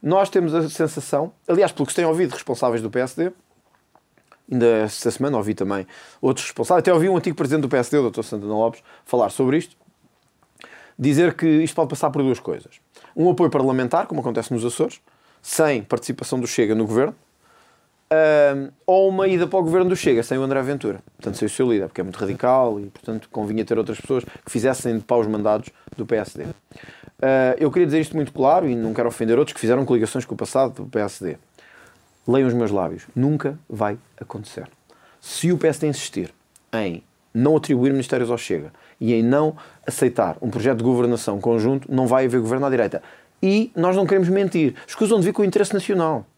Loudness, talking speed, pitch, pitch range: -21 LUFS, 200 wpm, 130 Hz, 115-160 Hz